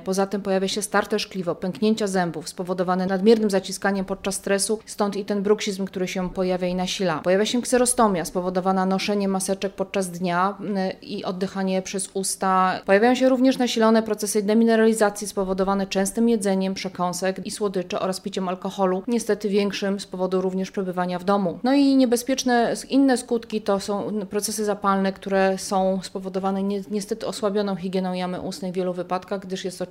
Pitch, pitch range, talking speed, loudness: 195 Hz, 190-210 Hz, 165 wpm, -23 LUFS